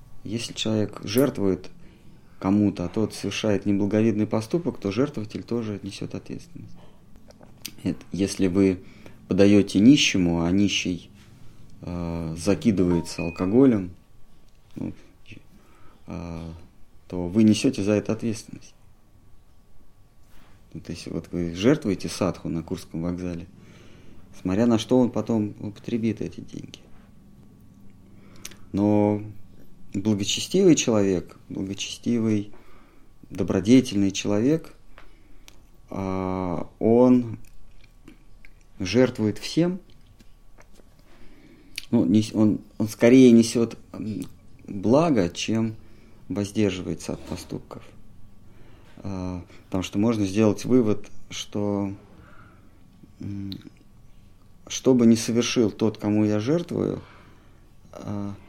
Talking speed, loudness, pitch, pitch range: 85 wpm, -23 LUFS, 100 Hz, 95-110 Hz